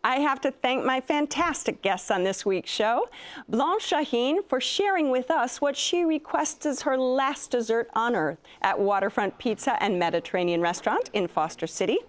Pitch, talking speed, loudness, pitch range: 255 Hz, 175 wpm, -26 LUFS, 200-295 Hz